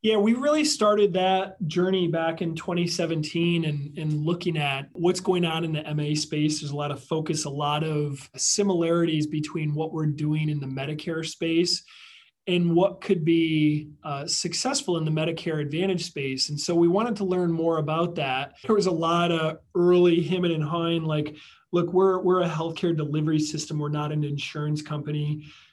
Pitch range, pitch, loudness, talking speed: 150-175 Hz, 165 Hz, -25 LUFS, 185 wpm